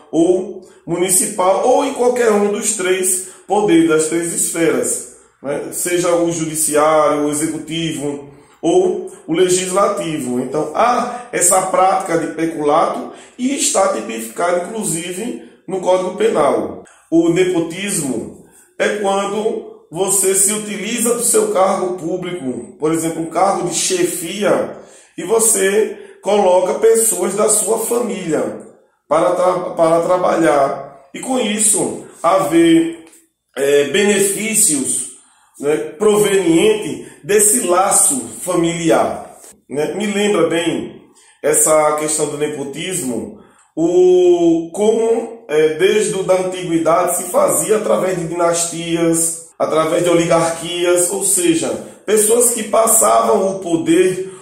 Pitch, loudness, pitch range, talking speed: 185 Hz, -15 LUFS, 165-235 Hz, 110 wpm